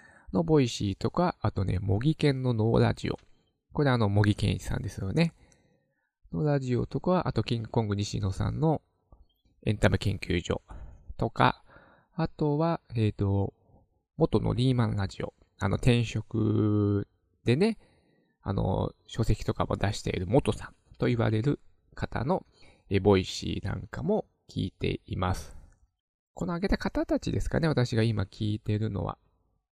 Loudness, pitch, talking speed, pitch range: -29 LUFS, 110 Hz, 290 characters per minute, 100-130 Hz